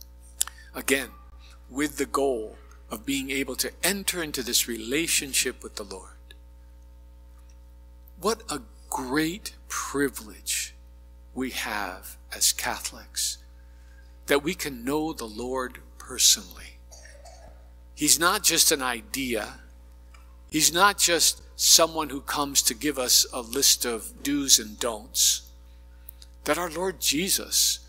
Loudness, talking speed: -24 LUFS, 115 wpm